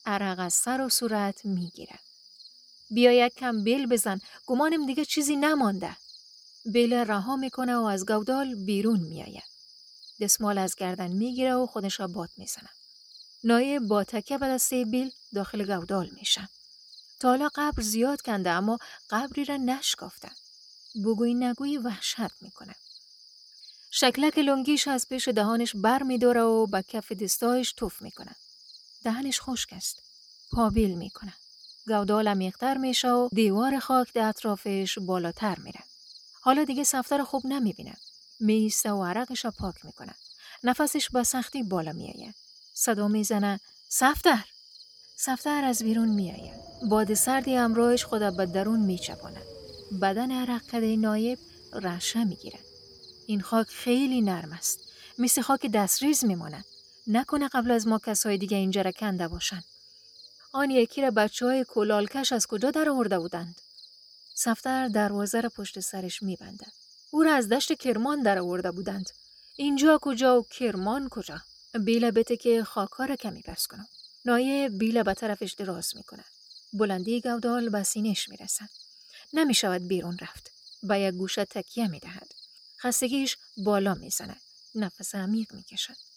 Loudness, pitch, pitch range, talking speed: -27 LUFS, 225 Hz, 200-255 Hz, 150 wpm